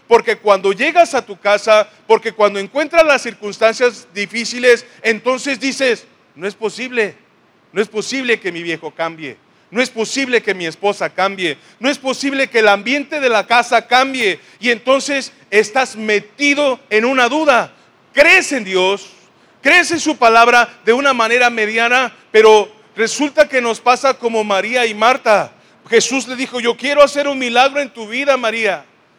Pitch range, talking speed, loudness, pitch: 215-270 Hz, 165 wpm, -14 LUFS, 235 Hz